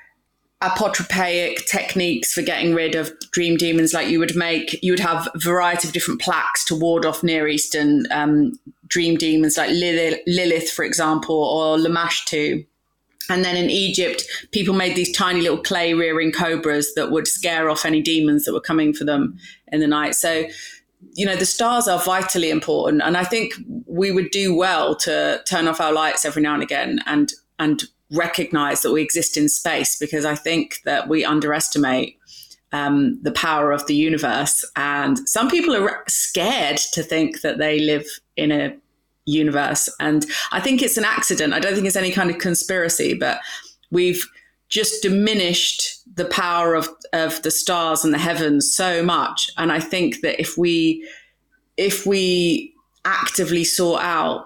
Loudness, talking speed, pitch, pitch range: -19 LUFS, 175 wpm, 165 Hz, 155-185 Hz